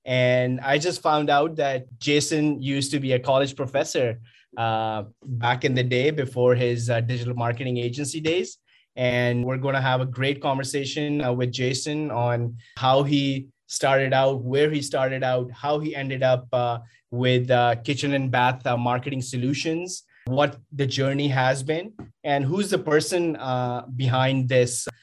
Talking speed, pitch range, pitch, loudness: 170 wpm, 125-145 Hz, 130 Hz, -24 LUFS